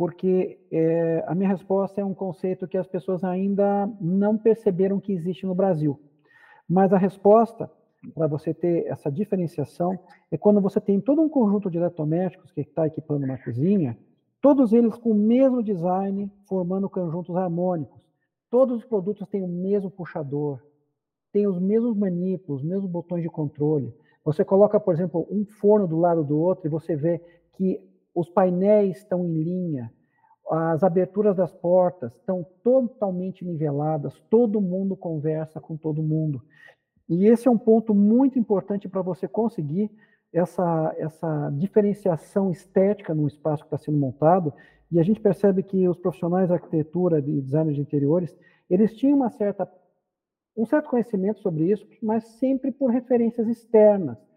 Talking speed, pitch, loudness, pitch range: 160 wpm, 185 Hz, -23 LUFS, 160-205 Hz